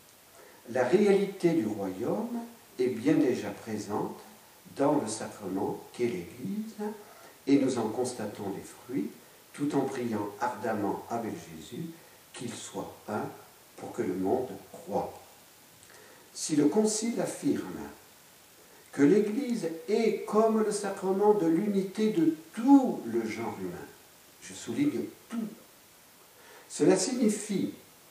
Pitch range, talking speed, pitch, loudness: 140-225 Hz, 115 wpm, 200 Hz, -30 LUFS